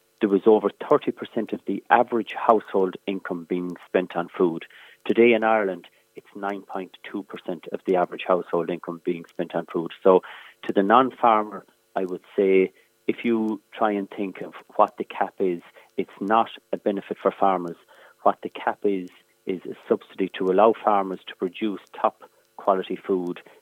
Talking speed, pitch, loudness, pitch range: 170 wpm, 95 Hz, -24 LUFS, 90-105 Hz